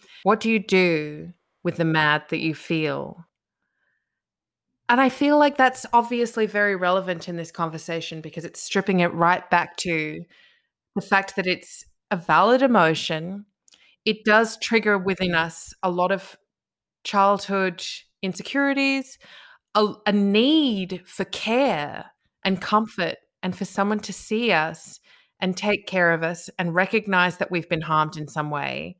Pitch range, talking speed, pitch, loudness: 170-215 Hz, 150 wpm, 190 Hz, -22 LUFS